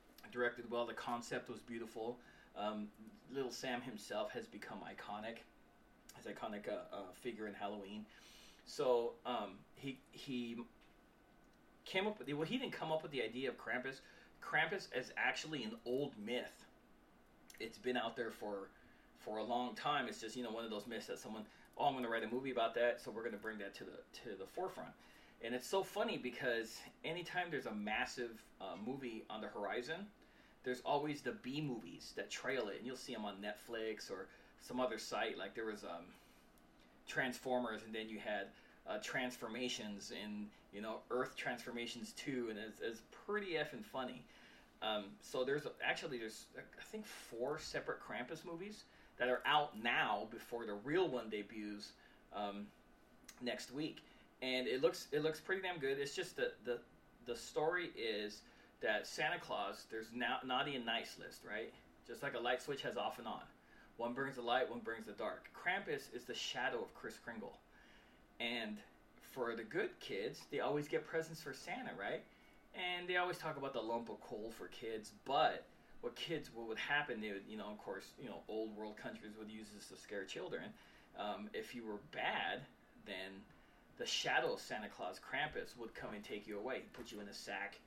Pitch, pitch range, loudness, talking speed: 120 Hz, 110-145 Hz, -43 LUFS, 195 wpm